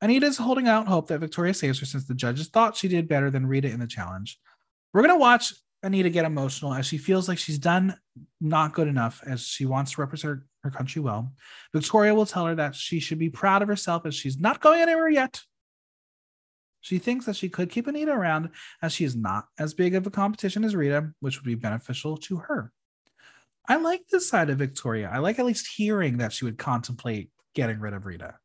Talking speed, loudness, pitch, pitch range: 225 wpm, -25 LUFS, 160 Hz, 135-200 Hz